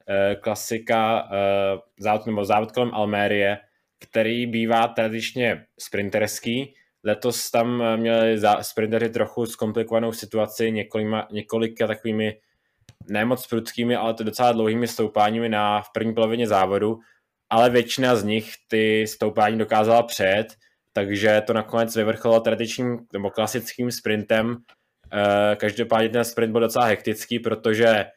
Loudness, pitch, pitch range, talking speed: -22 LUFS, 110 Hz, 105-115 Hz, 115 wpm